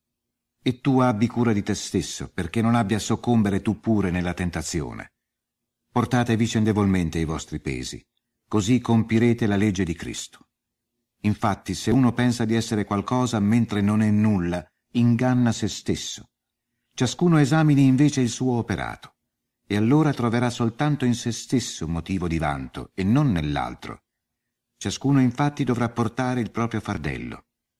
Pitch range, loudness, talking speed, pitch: 100-120 Hz, -23 LUFS, 145 wpm, 115 Hz